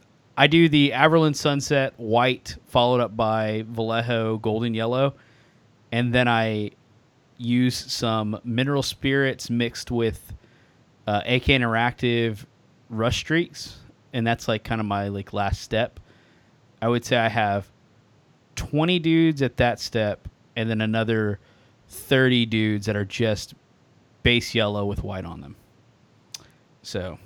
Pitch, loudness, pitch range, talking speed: 115 Hz, -23 LUFS, 110-130 Hz, 130 wpm